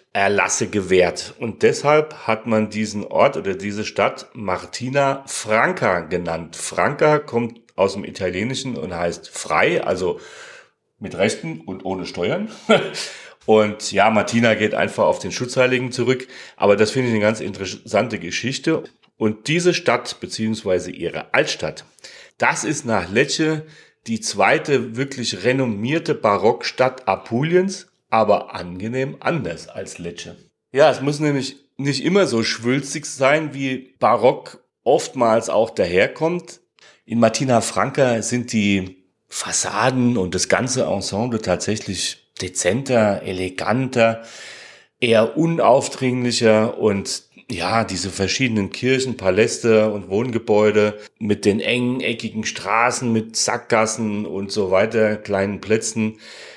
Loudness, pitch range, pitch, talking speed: -20 LUFS, 105-130 Hz, 115 Hz, 120 wpm